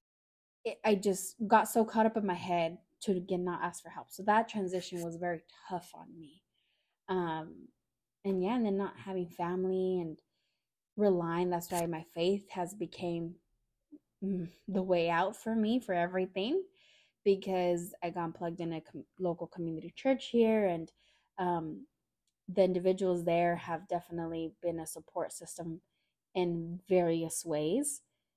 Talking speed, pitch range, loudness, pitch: 150 wpm, 170-195 Hz, -34 LUFS, 180 Hz